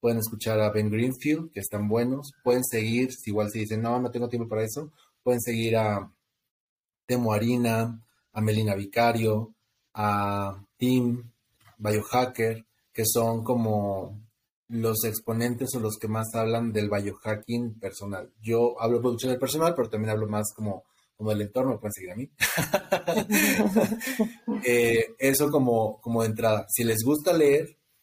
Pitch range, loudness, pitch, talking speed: 110-125 Hz, -26 LUFS, 115 Hz, 150 wpm